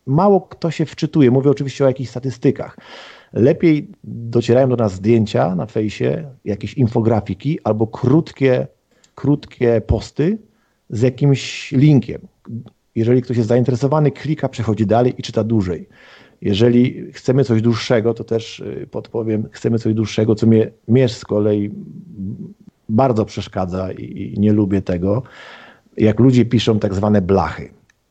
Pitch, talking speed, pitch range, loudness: 120 Hz, 130 wpm, 110-135 Hz, -17 LUFS